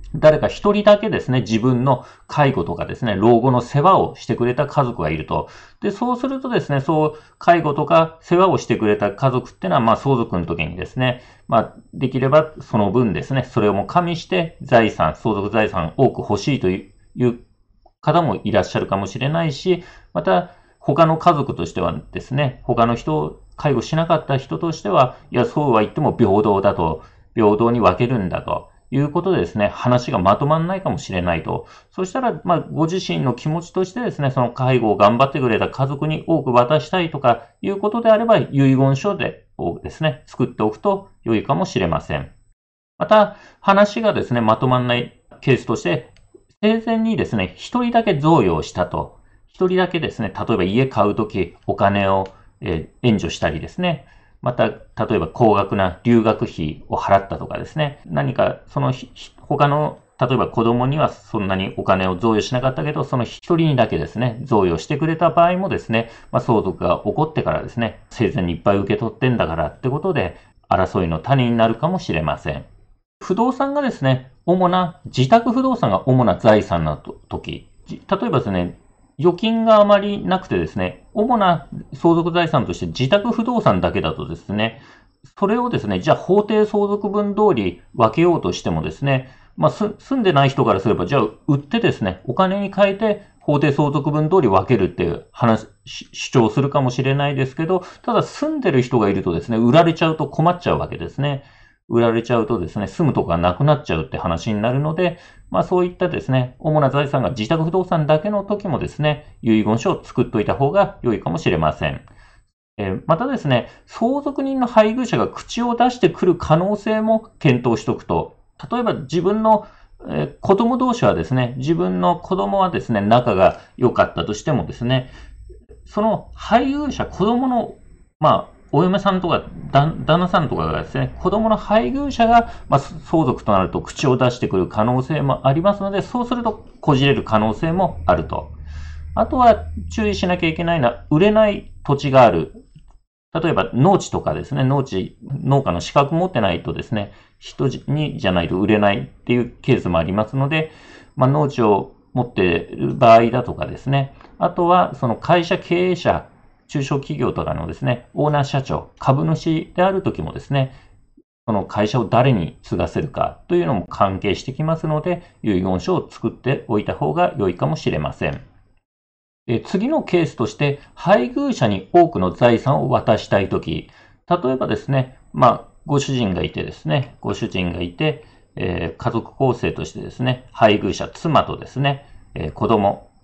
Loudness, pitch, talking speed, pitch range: -19 LUFS, 140 Hz, 360 characters per minute, 115-180 Hz